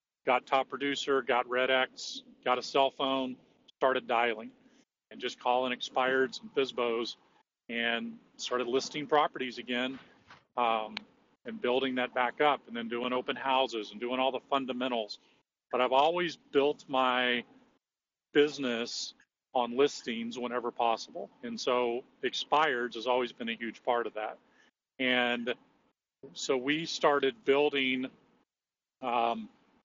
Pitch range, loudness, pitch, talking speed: 120-135 Hz, -31 LUFS, 125 Hz, 135 wpm